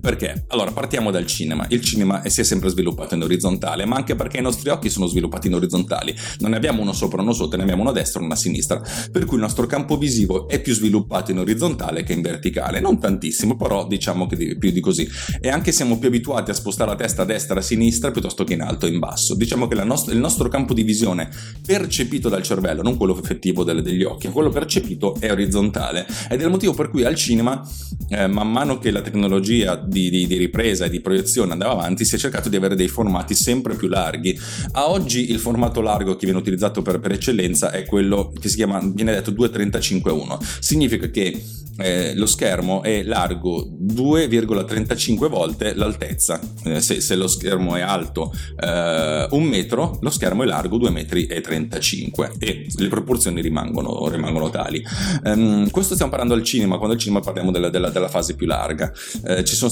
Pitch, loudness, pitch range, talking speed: 105 Hz, -20 LUFS, 90-115 Hz, 205 wpm